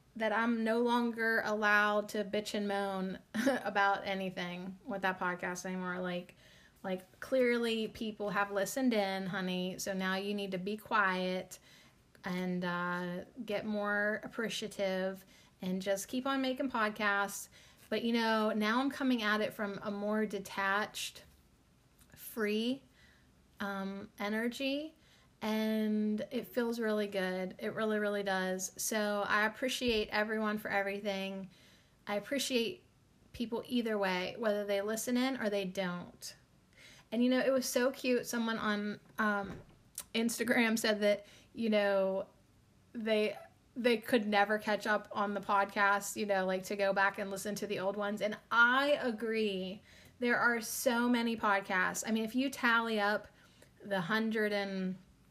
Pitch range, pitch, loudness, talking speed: 195-225 Hz, 210 Hz, -34 LUFS, 150 wpm